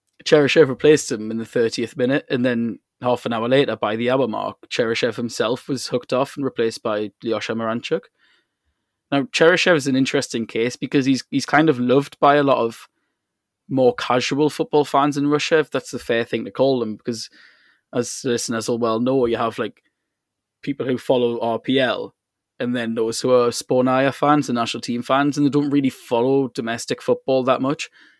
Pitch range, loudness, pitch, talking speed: 115-140 Hz, -20 LUFS, 130 Hz, 190 wpm